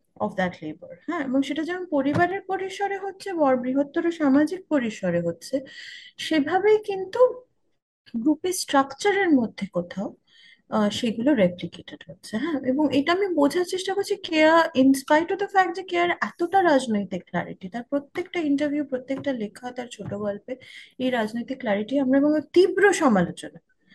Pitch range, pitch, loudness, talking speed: 230-360 Hz, 280 Hz, -24 LUFS, 140 wpm